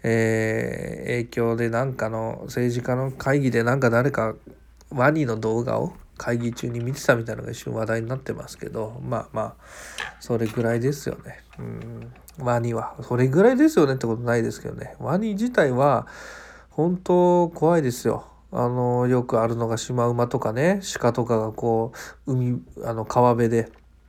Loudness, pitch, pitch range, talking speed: -23 LUFS, 120 Hz, 115-130 Hz, 320 characters per minute